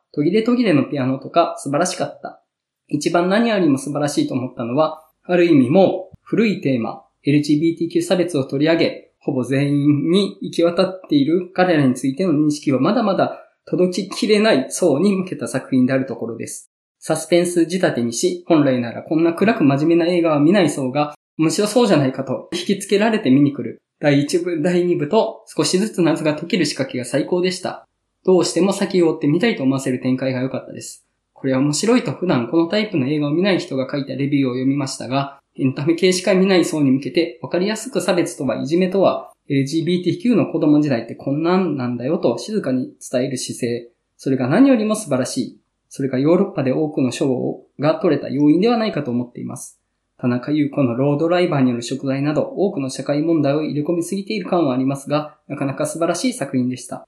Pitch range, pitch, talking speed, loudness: 135-180 Hz, 155 Hz, 425 characters per minute, -19 LUFS